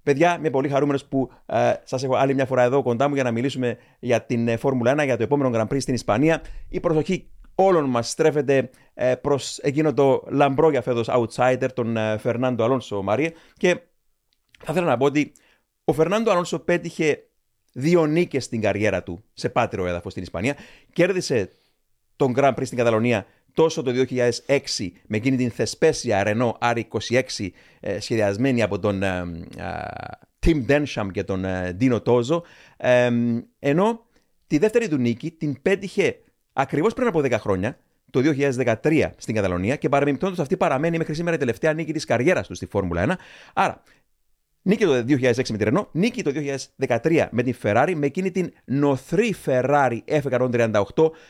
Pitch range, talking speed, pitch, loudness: 115-155 Hz, 165 wpm, 130 Hz, -22 LUFS